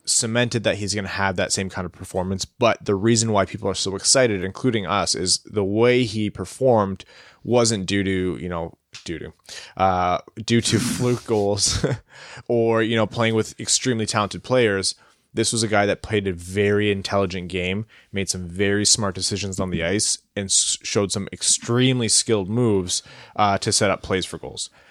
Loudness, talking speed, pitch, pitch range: -21 LUFS, 190 wpm, 100 Hz, 95-115 Hz